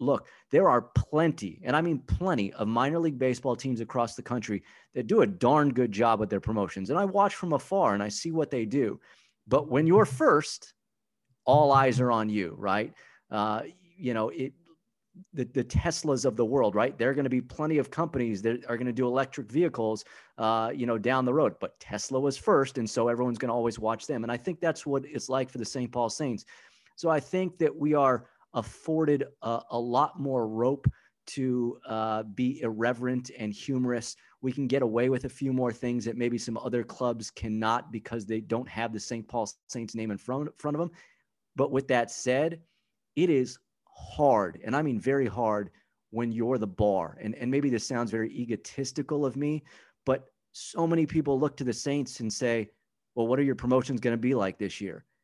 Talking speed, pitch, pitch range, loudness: 215 wpm, 125 Hz, 115-140 Hz, -29 LUFS